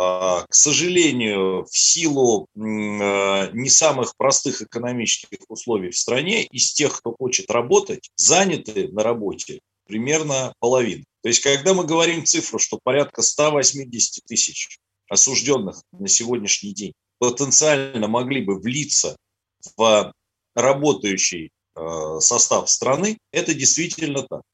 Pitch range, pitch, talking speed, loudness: 100-150 Hz, 130 Hz, 115 wpm, -18 LUFS